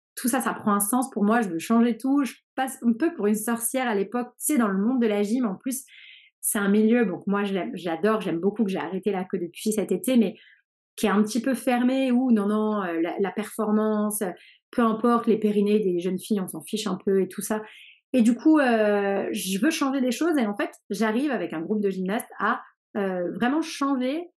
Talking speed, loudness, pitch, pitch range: 240 wpm, -25 LUFS, 215 Hz, 200-250 Hz